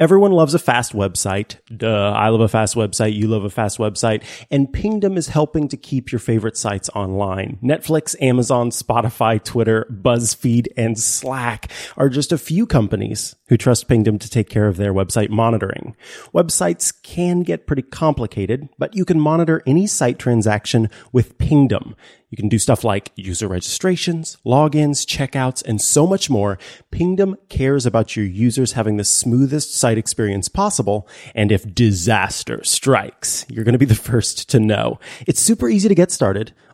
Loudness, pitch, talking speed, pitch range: -18 LUFS, 120 Hz, 170 wpm, 110-145 Hz